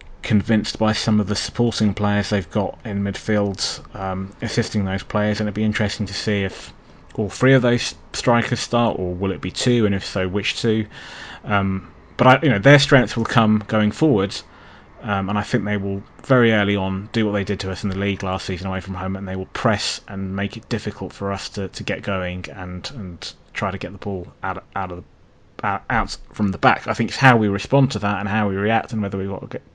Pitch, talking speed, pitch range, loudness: 105 Hz, 240 wpm, 95-110 Hz, -20 LUFS